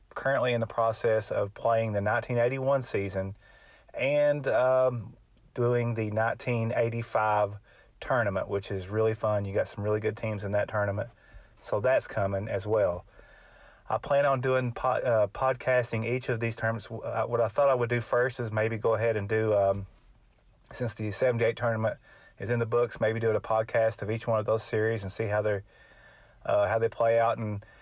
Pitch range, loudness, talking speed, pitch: 105-120 Hz, -28 LUFS, 185 wpm, 115 Hz